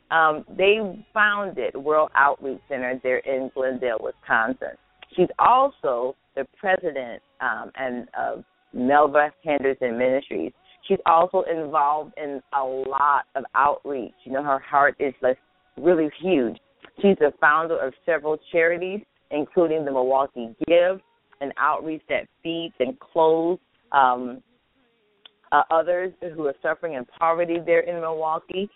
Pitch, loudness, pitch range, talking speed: 155 Hz, -23 LUFS, 135-175 Hz, 135 wpm